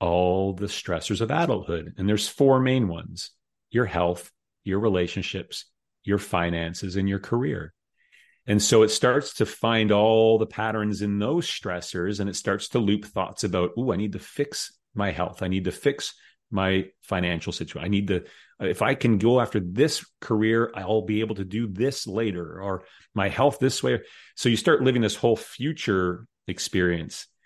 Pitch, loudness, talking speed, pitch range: 105 Hz, -25 LUFS, 180 wpm, 95-115 Hz